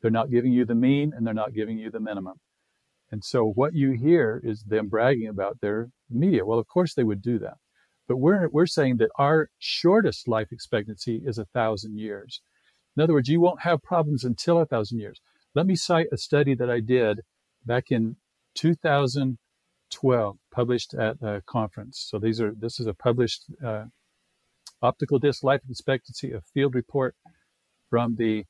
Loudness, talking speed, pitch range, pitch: -25 LUFS, 185 wpm, 110-140 Hz, 120 Hz